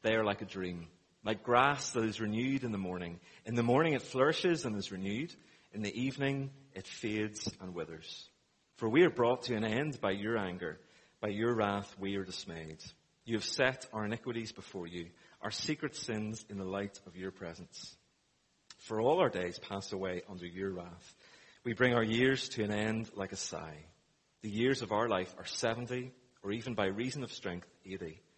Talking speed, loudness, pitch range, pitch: 195 wpm, -35 LUFS, 95-120 Hz, 105 Hz